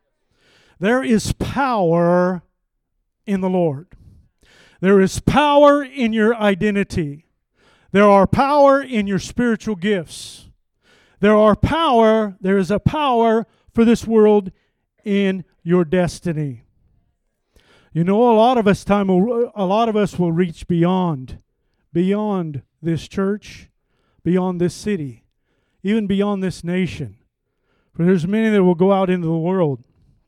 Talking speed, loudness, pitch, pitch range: 135 wpm, -17 LUFS, 195 Hz, 175-215 Hz